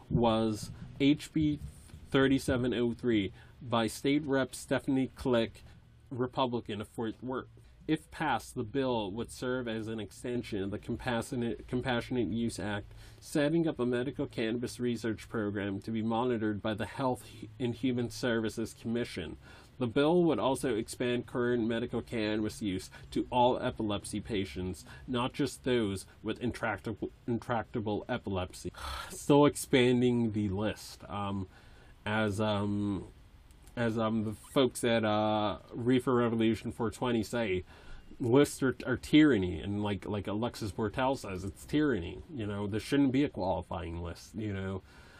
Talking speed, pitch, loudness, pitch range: 140 wpm, 115 Hz, -32 LUFS, 105-125 Hz